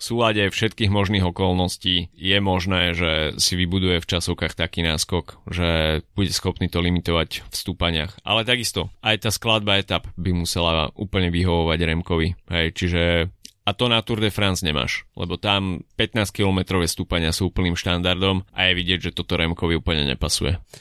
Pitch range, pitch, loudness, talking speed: 85-100 Hz, 90 Hz, -21 LUFS, 160 wpm